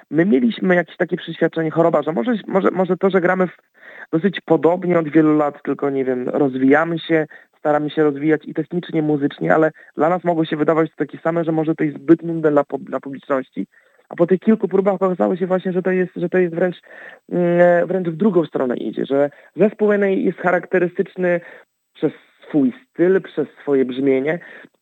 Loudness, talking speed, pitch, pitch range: -18 LUFS, 185 wpm, 165 Hz, 150-185 Hz